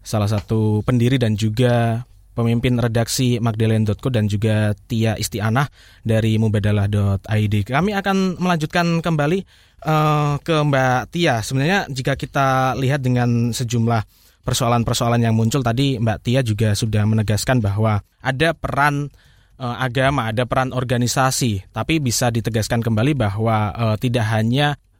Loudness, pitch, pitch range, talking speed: -19 LUFS, 120 Hz, 110-135 Hz, 125 wpm